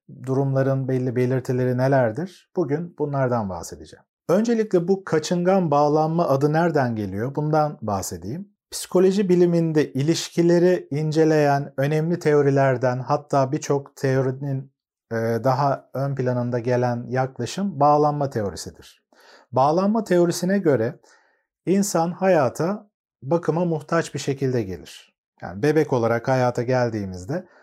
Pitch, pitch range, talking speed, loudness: 145 Hz, 130-170 Hz, 100 wpm, -22 LUFS